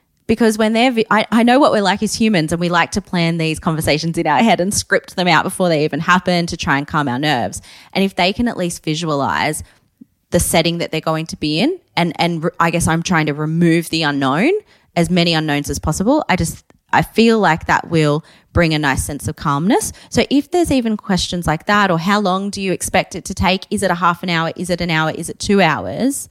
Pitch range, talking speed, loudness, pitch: 160-205 Hz, 250 wpm, -16 LUFS, 175 Hz